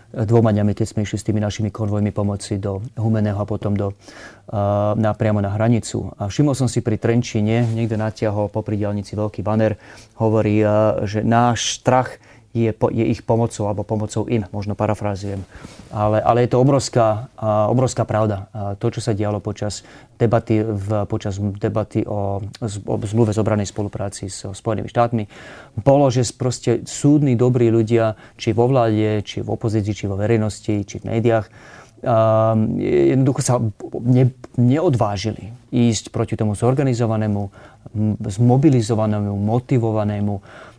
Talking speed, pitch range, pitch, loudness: 150 wpm, 105-120 Hz, 110 Hz, -19 LUFS